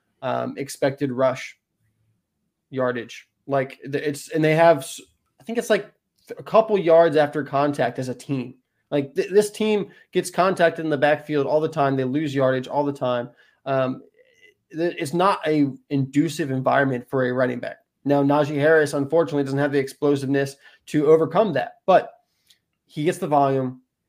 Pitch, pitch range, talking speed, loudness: 145 Hz, 135-165 Hz, 160 wpm, -22 LUFS